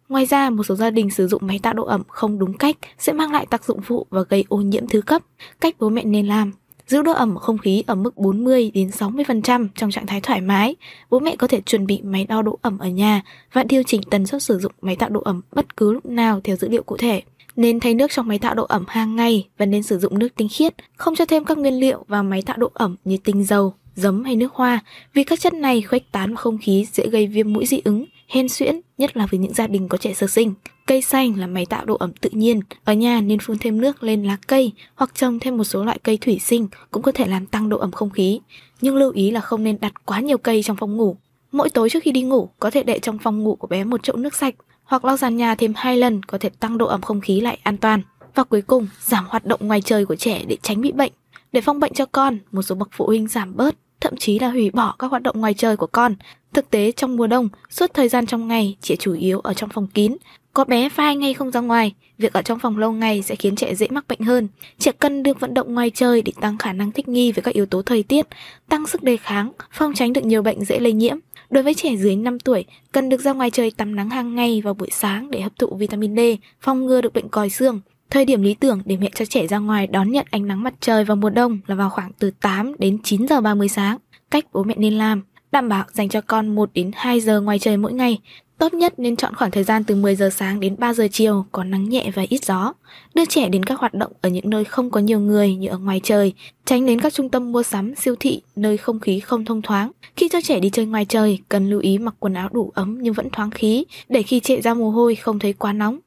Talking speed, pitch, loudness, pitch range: 275 wpm, 225 Hz, -19 LUFS, 205-255 Hz